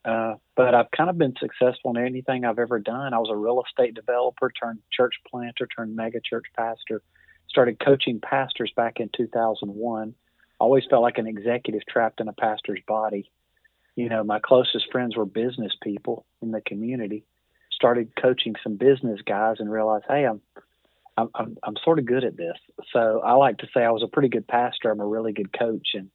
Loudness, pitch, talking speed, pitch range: -24 LUFS, 115 Hz, 195 wpm, 110-125 Hz